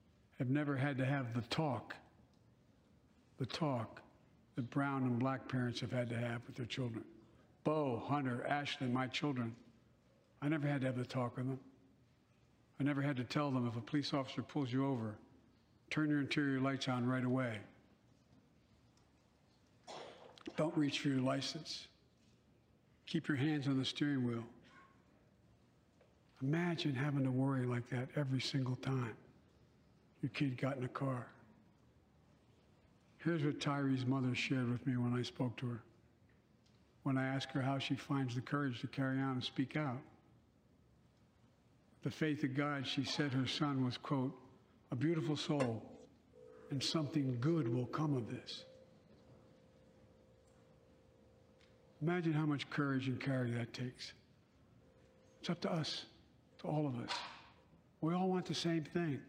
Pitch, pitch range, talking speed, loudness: 135 Hz, 125-145 Hz, 155 wpm, -39 LUFS